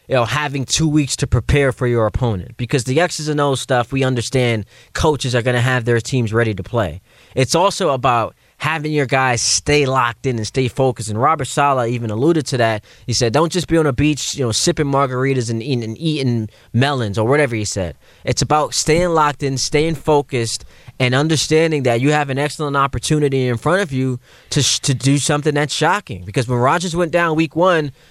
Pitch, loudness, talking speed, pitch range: 135 Hz, -17 LUFS, 215 wpm, 120-150 Hz